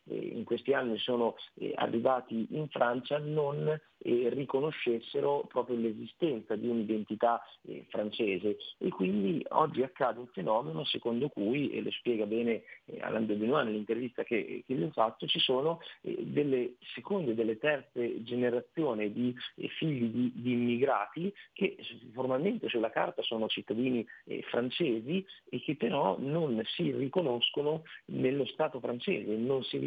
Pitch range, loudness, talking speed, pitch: 115-145 Hz, -33 LUFS, 130 wpm, 125 Hz